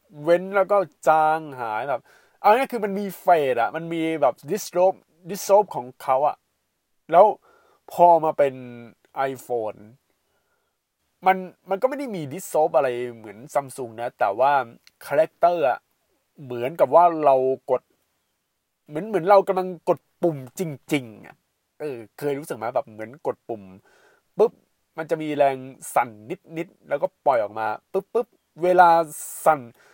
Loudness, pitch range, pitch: -22 LUFS, 130-190 Hz, 160 Hz